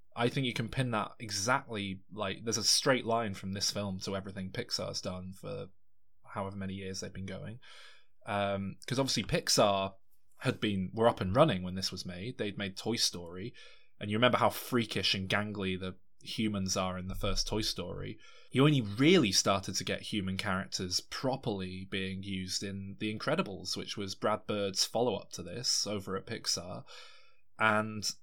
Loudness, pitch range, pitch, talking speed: -32 LUFS, 95-110 Hz, 100 Hz, 180 wpm